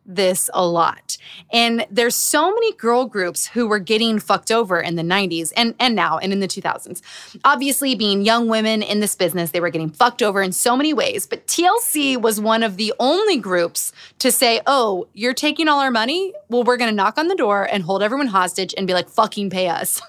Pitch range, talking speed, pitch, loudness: 195-255 Hz, 220 wpm, 225 Hz, -18 LUFS